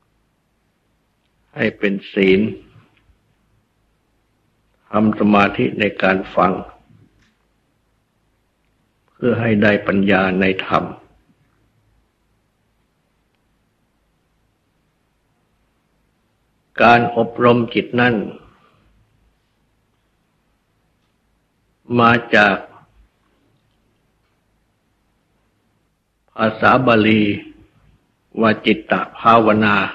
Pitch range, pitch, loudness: 100-115 Hz, 110 Hz, -16 LUFS